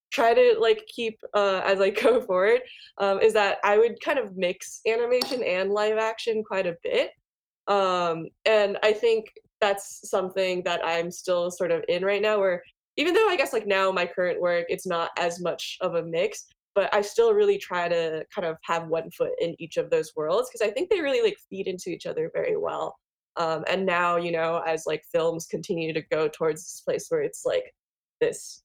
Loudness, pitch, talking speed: -25 LUFS, 200 Hz, 210 wpm